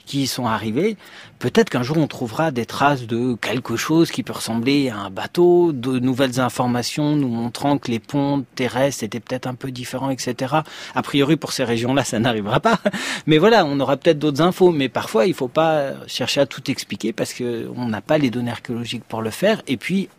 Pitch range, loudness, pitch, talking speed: 120-155 Hz, -20 LUFS, 130 Hz, 210 wpm